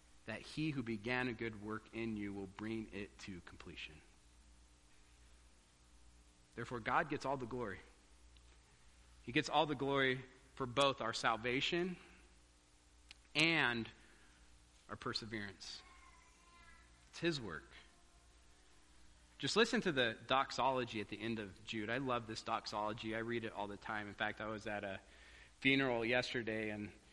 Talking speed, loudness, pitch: 140 wpm, -39 LUFS, 105 Hz